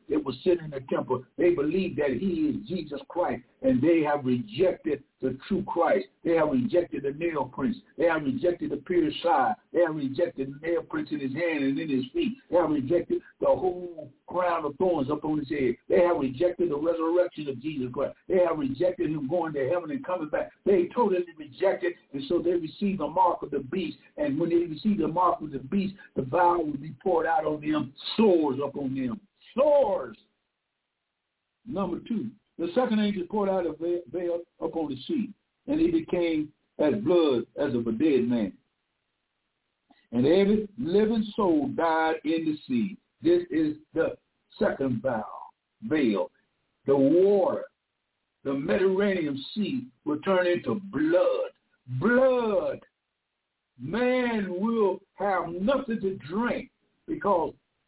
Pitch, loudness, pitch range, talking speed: 180 Hz, -27 LUFS, 155-235 Hz, 165 wpm